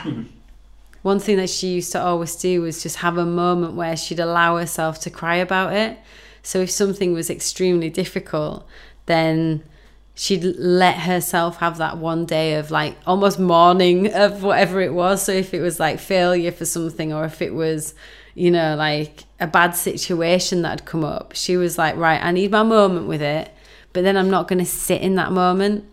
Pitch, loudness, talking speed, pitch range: 175 Hz, -19 LUFS, 195 wpm, 165-185 Hz